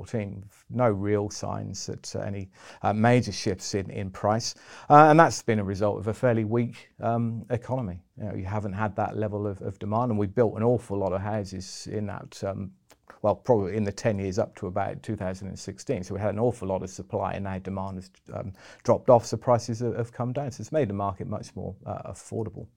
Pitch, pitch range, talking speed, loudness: 105 Hz, 100-115 Hz, 220 wpm, -27 LUFS